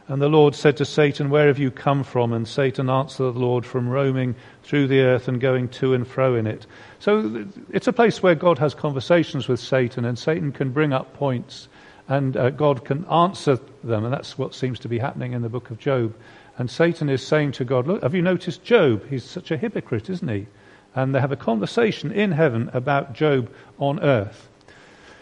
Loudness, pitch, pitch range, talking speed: -22 LUFS, 135 Hz, 125-150 Hz, 210 wpm